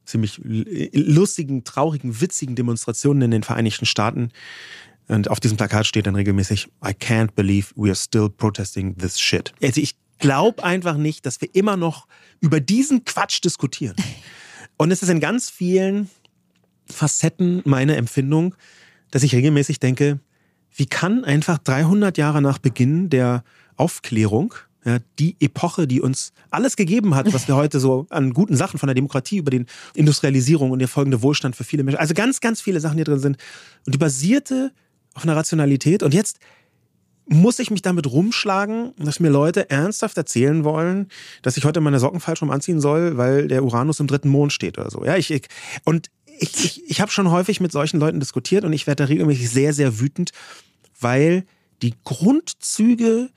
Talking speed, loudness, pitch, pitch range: 175 wpm, -19 LUFS, 145 Hz, 130-175 Hz